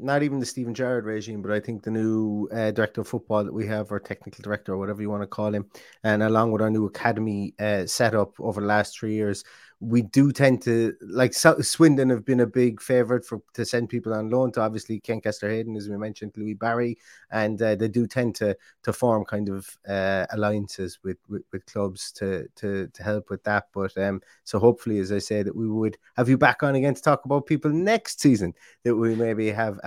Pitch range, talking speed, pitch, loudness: 105-120 Hz, 230 wpm, 110 Hz, -25 LUFS